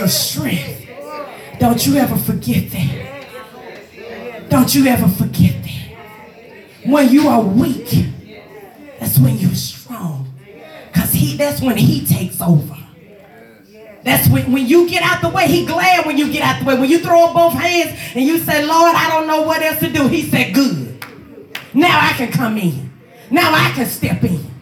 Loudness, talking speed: -14 LUFS, 175 wpm